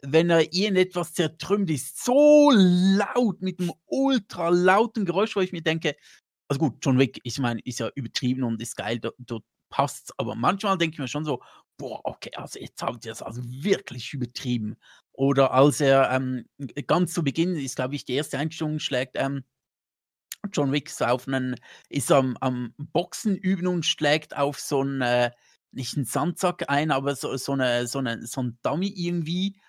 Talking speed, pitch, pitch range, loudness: 185 wpm, 145 Hz, 130-175 Hz, -25 LUFS